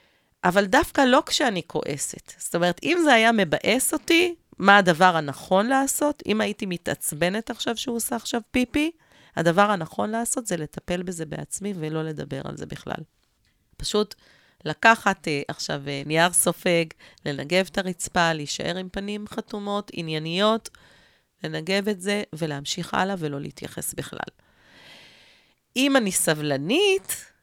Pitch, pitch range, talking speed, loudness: 200 Hz, 170-235 Hz, 130 wpm, -23 LUFS